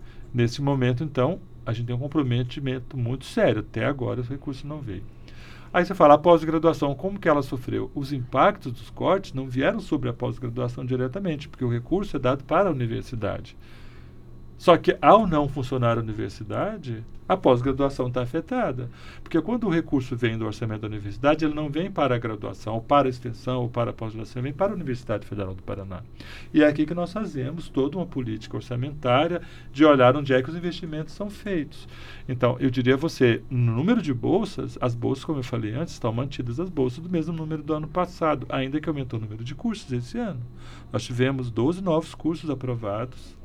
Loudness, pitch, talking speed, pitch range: -25 LUFS, 130 Hz, 200 wpm, 120-155 Hz